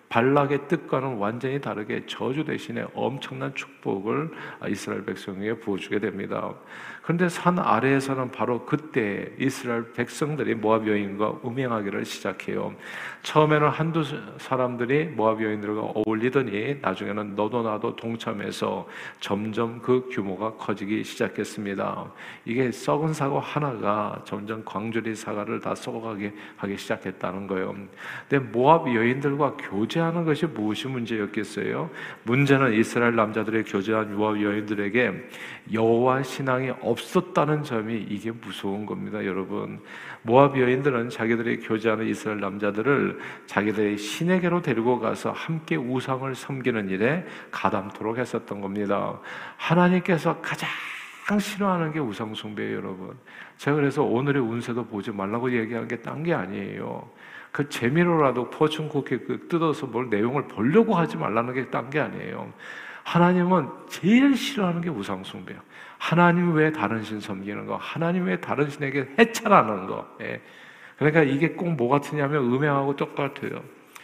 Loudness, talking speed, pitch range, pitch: -25 LUFS, 335 characters per minute, 105-145 Hz, 120 Hz